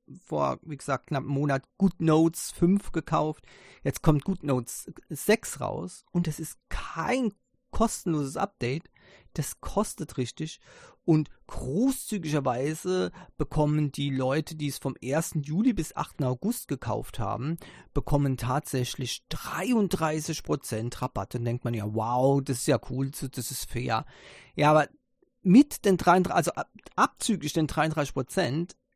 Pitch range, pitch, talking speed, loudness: 135-175 Hz, 150 Hz, 135 wpm, -28 LUFS